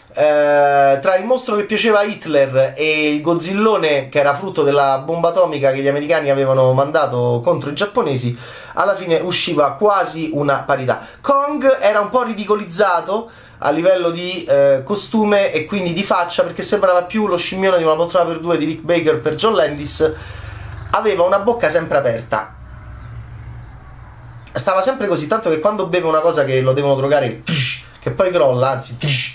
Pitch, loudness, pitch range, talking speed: 160 Hz, -16 LUFS, 135-195 Hz, 175 wpm